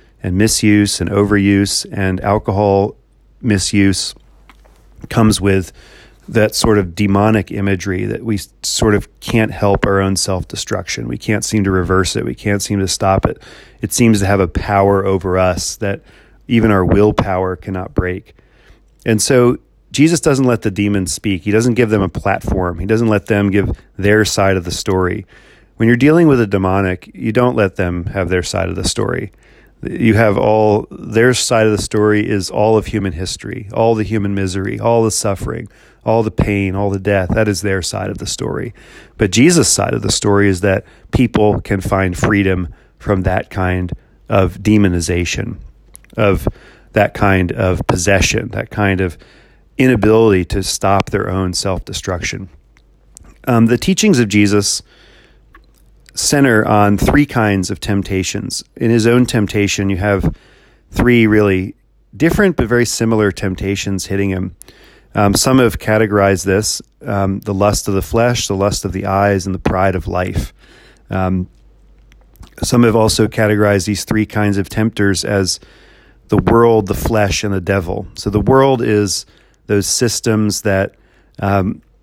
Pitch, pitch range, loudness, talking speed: 100 Hz, 95-110 Hz, -15 LUFS, 165 wpm